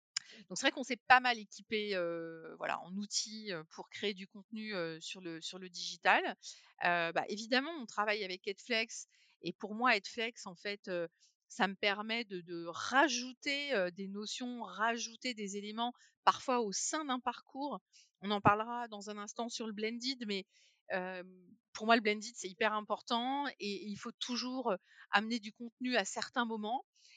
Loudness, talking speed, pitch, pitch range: -36 LUFS, 180 wpm, 215 Hz, 195-240 Hz